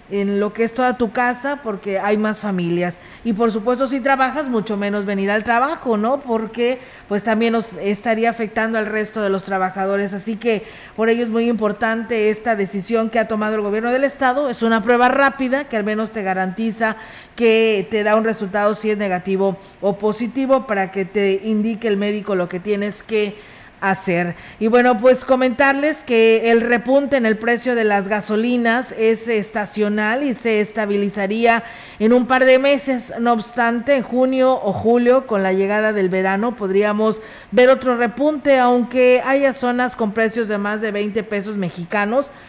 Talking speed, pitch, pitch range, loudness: 180 wpm, 225 Hz, 205-245 Hz, -18 LUFS